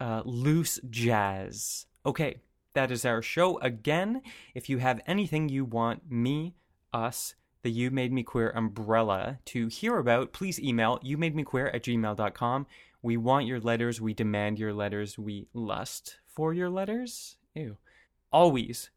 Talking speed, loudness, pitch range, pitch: 150 wpm, -30 LUFS, 115-150 Hz, 125 Hz